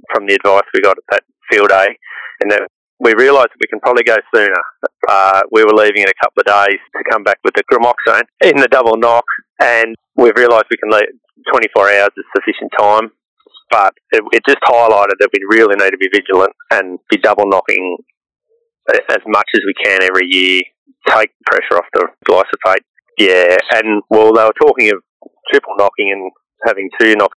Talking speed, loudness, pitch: 195 wpm, -11 LUFS, 110 Hz